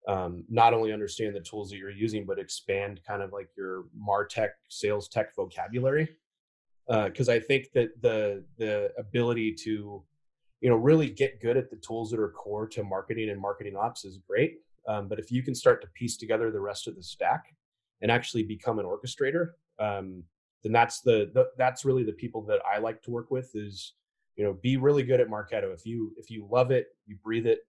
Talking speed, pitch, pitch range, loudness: 210 wpm, 115 Hz, 105-135 Hz, -29 LUFS